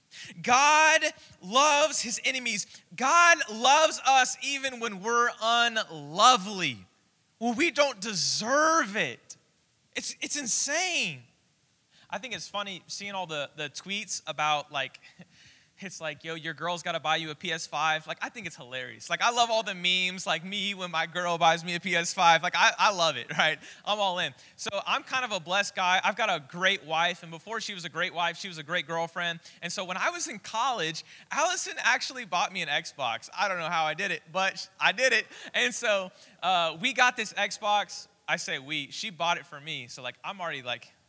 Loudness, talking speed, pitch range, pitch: -27 LUFS, 200 wpm, 165-235 Hz, 190 Hz